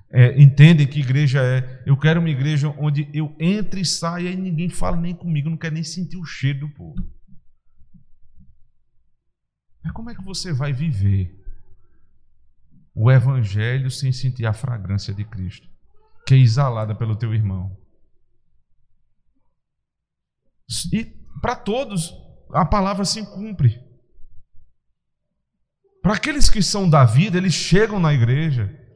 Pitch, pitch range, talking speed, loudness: 145 Hz, 115-170 Hz, 135 wpm, -19 LUFS